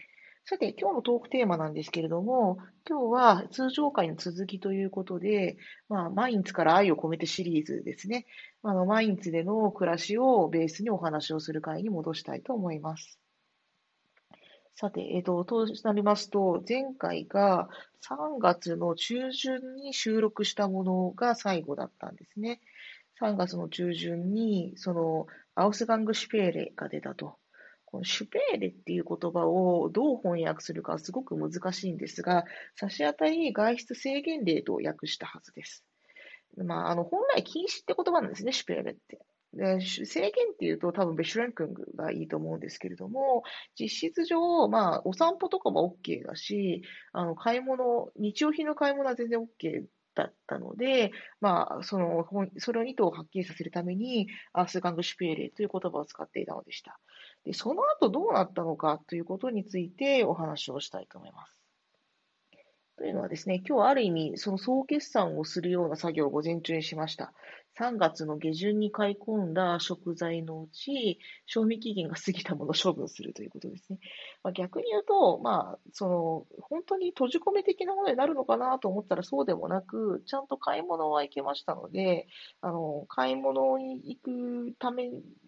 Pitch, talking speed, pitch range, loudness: 195 Hz, 350 characters per minute, 170-245 Hz, -30 LUFS